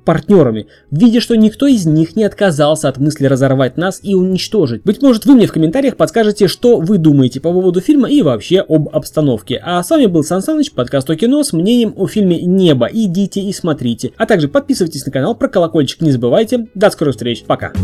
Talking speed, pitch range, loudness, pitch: 210 wpm, 150-220 Hz, -12 LUFS, 180 Hz